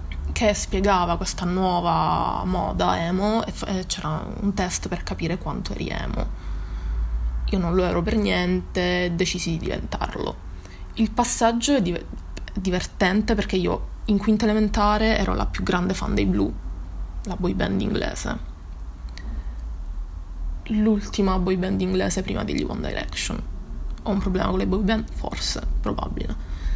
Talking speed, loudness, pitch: 135 wpm, -24 LUFS, 180 Hz